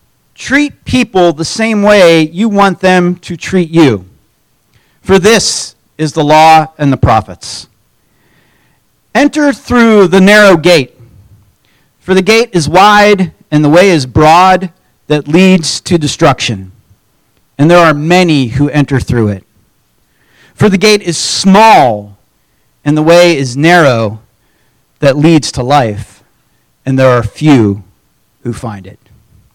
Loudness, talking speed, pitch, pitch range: -8 LUFS, 135 wpm, 150 Hz, 115-185 Hz